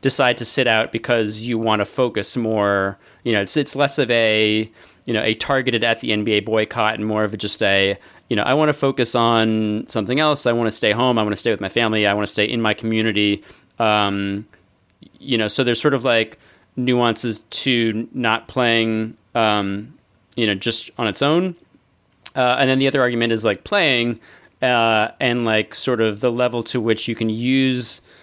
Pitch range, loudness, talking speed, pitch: 110-125 Hz, -19 LUFS, 210 wpm, 115 Hz